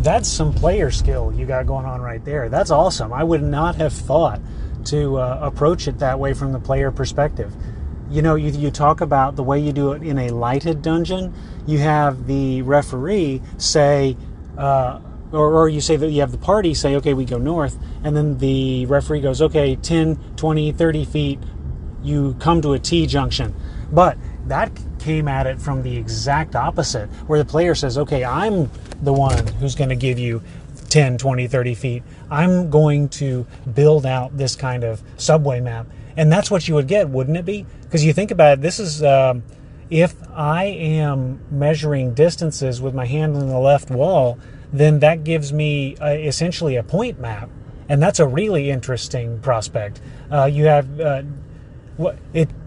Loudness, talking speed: -19 LUFS, 185 wpm